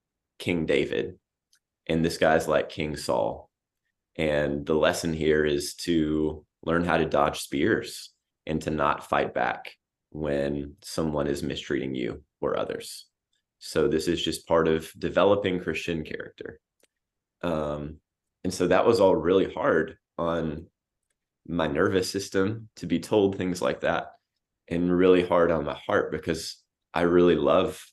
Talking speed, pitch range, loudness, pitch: 145 wpm, 75-90 Hz, -26 LUFS, 80 Hz